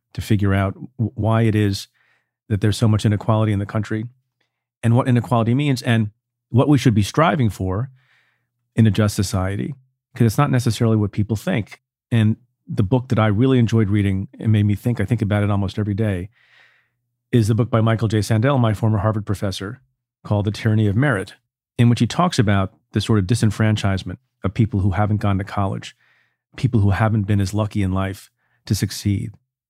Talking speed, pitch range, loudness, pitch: 195 wpm, 105-120 Hz, -20 LUFS, 110 Hz